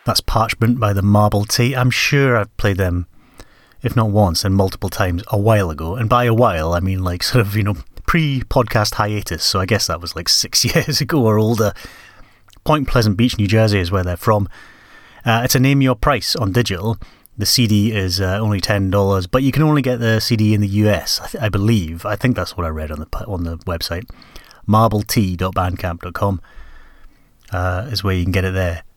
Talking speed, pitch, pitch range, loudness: 210 wpm, 105 Hz, 95-115 Hz, -17 LUFS